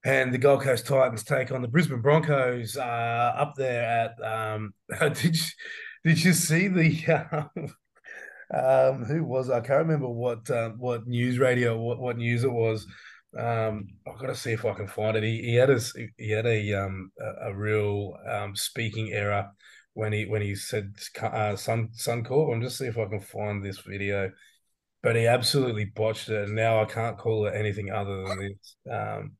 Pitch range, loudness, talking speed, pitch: 105-130 Hz, -27 LUFS, 195 wpm, 115 Hz